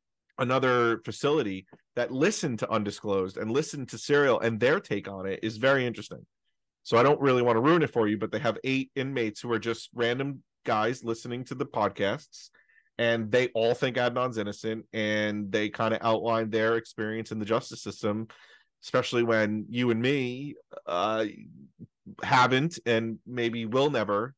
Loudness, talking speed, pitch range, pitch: -28 LUFS, 170 wpm, 110-130 Hz, 115 Hz